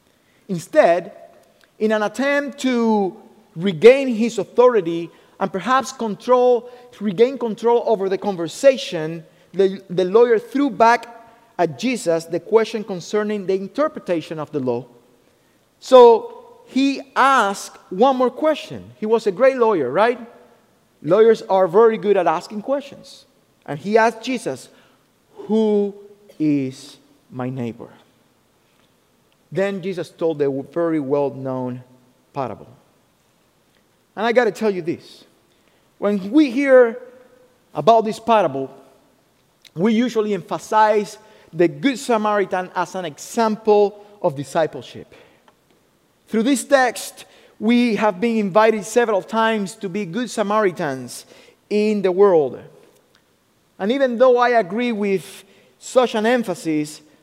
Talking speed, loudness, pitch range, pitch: 120 wpm, -19 LUFS, 185-240 Hz, 215 Hz